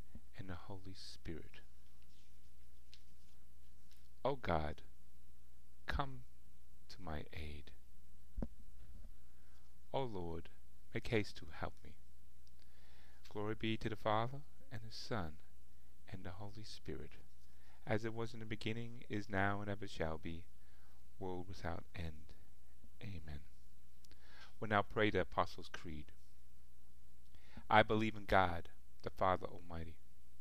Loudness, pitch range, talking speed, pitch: -42 LUFS, 60-95 Hz, 115 wpm, 65 Hz